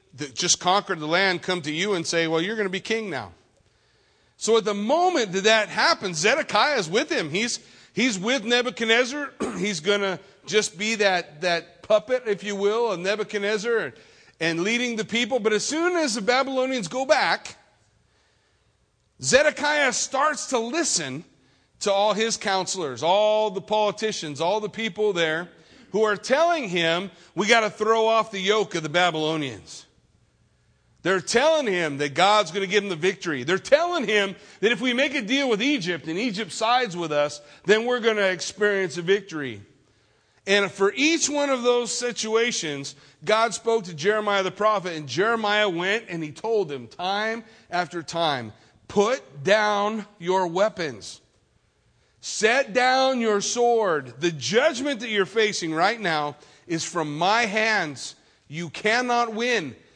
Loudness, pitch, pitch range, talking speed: -23 LUFS, 205 Hz, 170-230 Hz, 165 wpm